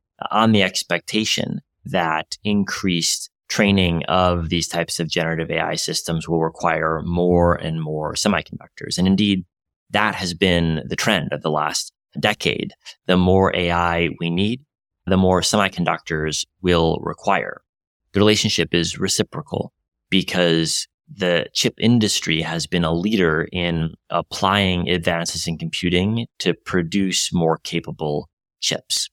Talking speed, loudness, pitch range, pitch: 130 wpm, -20 LUFS, 80-95 Hz, 85 Hz